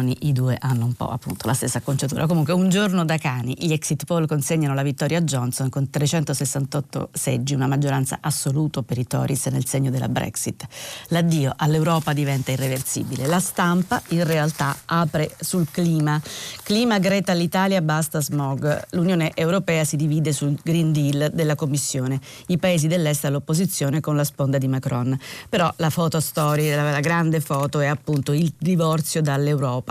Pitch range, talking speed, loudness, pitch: 140-165 Hz, 165 wpm, -22 LUFS, 150 Hz